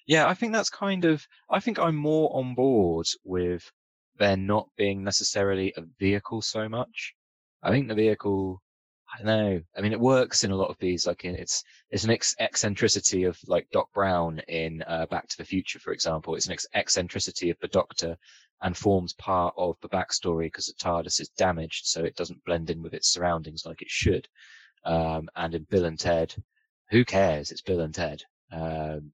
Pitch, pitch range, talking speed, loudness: 95 Hz, 85-110 Hz, 200 wpm, -27 LUFS